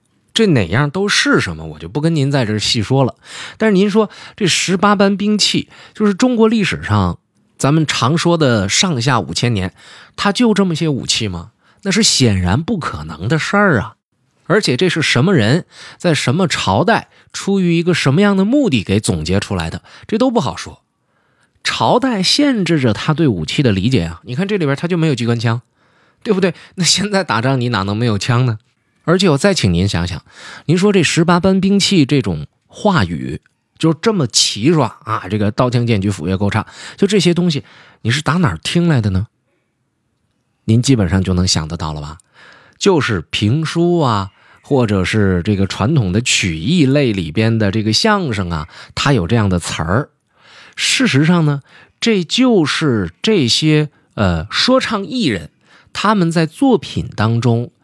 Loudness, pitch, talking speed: -15 LUFS, 135 Hz, 260 characters per minute